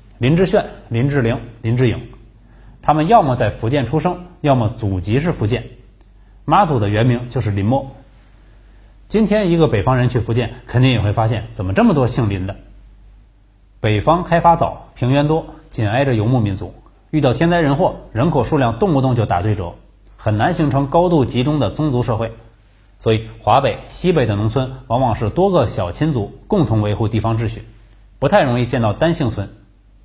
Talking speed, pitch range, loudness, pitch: 275 characters per minute, 105-140 Hz, -17 LUFS, 120 Hz